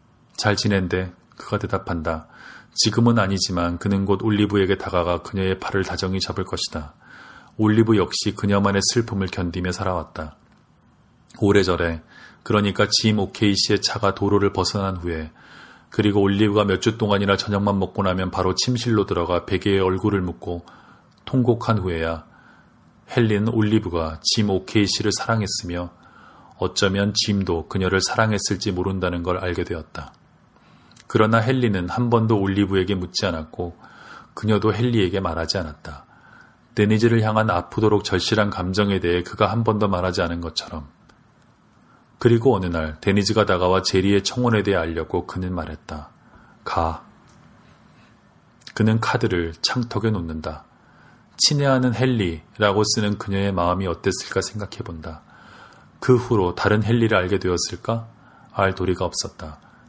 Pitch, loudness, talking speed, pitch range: 100 Hz, -21 LUFS, 315 characters per minute, 90-110 Hz